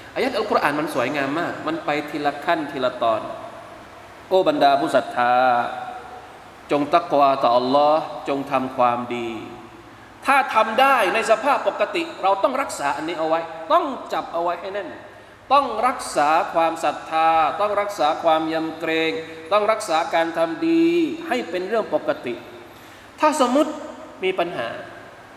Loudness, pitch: -21 LUFS, 190 Hz